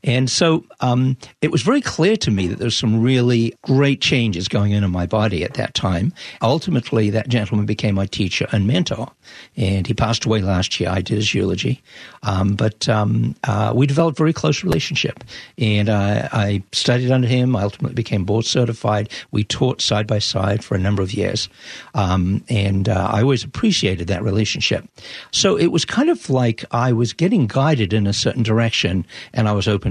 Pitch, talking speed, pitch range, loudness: 110 Hz, 195 wpm, 105-130 Hz, -19 LUFS